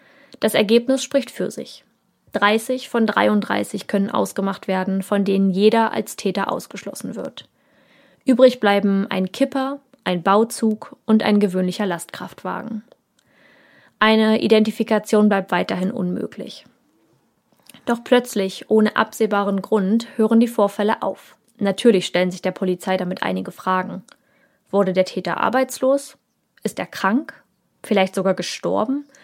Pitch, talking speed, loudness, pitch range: 210 Hz, 125 wpm, -20 LUFS, 190-235 Hz